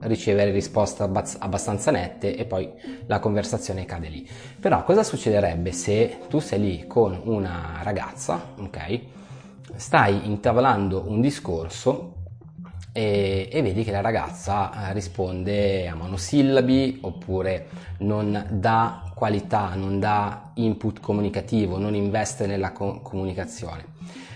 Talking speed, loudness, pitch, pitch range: 120 wpm, -24 LUFS, 100 Hz, 95-115 Hz